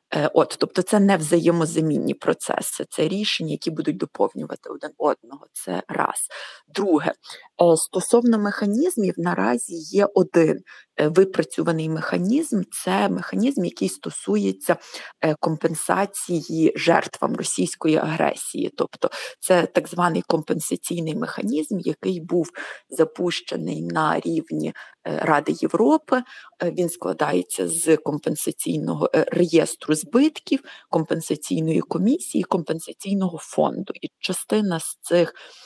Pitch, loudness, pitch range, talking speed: 175 Hz, -22 LUFS, 160-205 Hz, 100 wpm